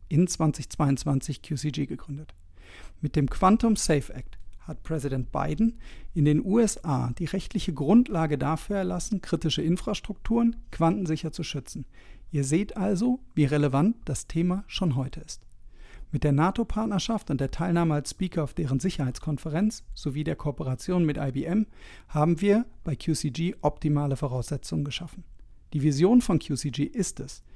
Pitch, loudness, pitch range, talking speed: 155 Hz, -27 LUFS, 140-185 Hz, 140 wpm